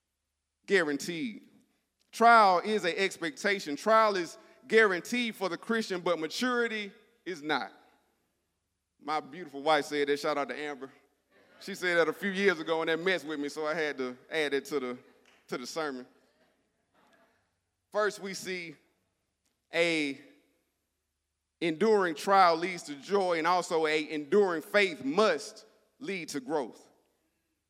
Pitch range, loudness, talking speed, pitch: 145-205 Hz, -29 LUFS, 140 wpm, 170 Hz